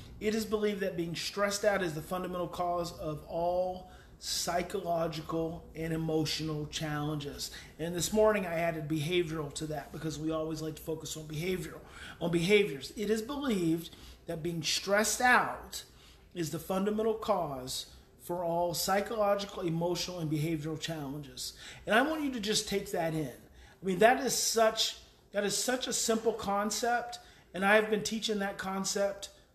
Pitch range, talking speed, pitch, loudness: 160-210 Hz, 160 wpm, 175 Hz, -32 LUFS